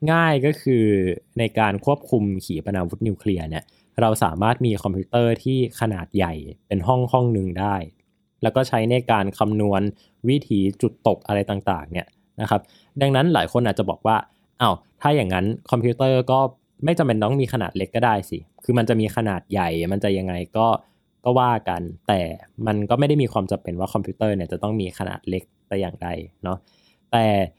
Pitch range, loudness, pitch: 95-120 Hz, -22 LUFS, 105 Hz